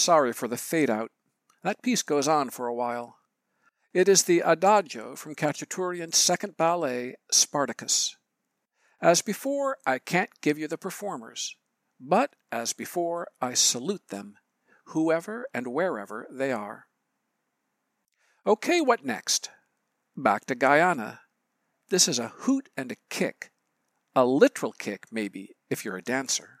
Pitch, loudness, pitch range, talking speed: 170 Hz, -26 LUFS, 130-200 Hz, 140 wpm